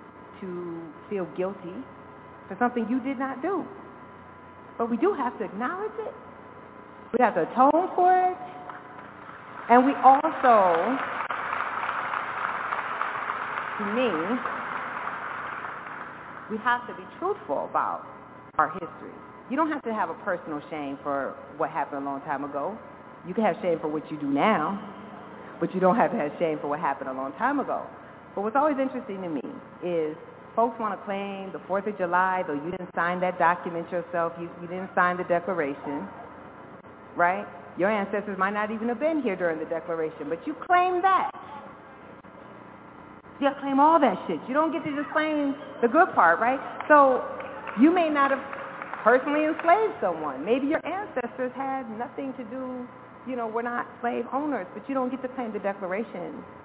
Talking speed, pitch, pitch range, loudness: 170 wpm, 230 Hz, 170-275 Hz, -26 LUFS